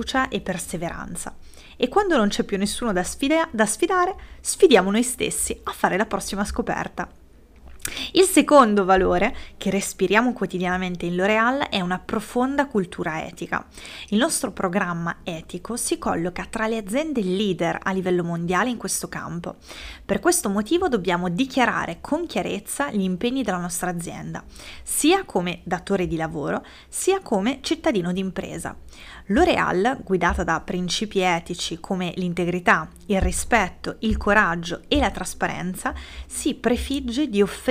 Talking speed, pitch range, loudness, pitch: 140 wpm, 180-245 Hz, -23 LUFS, 200 Hz